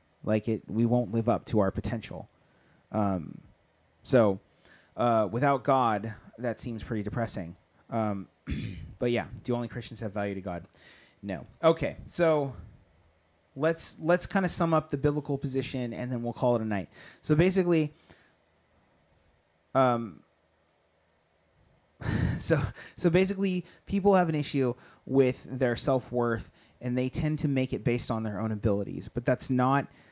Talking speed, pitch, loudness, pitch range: 150 wpm, 120 Hz, -29 LUFS, 100-140 Hz